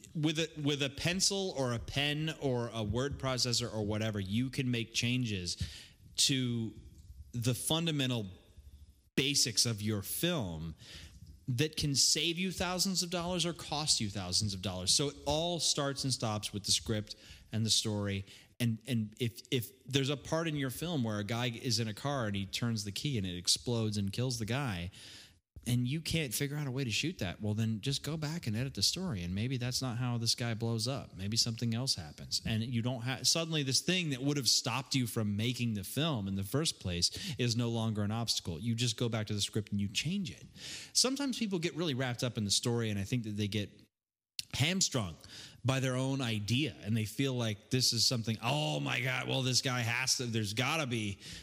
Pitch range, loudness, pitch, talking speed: 105-140 Hz, -33 LUFS, 120 Hz, 215 wpm